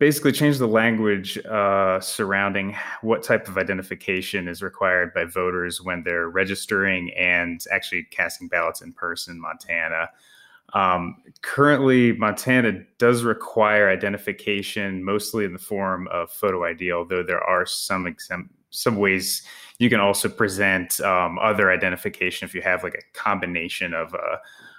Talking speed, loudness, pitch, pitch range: 145 wpm, -22 LUFS, 100 Hz, 90-110 Hz